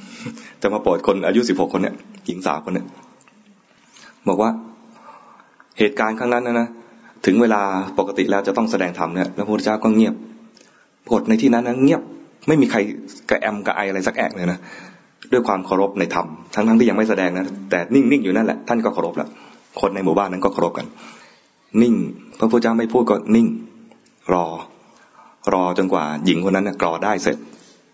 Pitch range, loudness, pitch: 95-125 Hz, -19 LUFS, 110 Hz